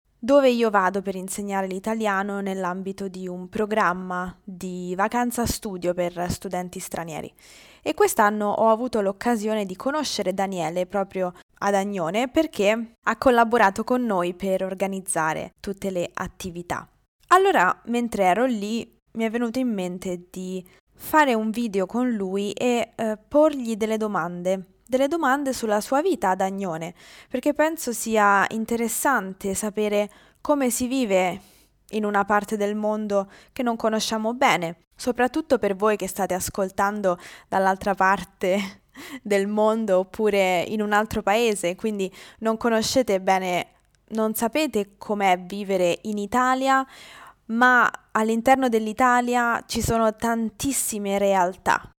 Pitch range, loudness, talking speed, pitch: 190-235 Hz, -23 LUFS, 130 wpm, 210 Hz